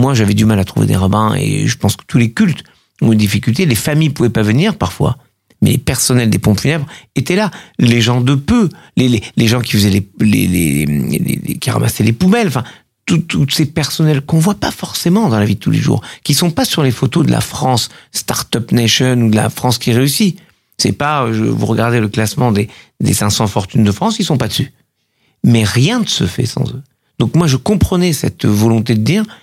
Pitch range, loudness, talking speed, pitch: 110-155 Hz, -13 LUFS, 245 wpm, 125 Hz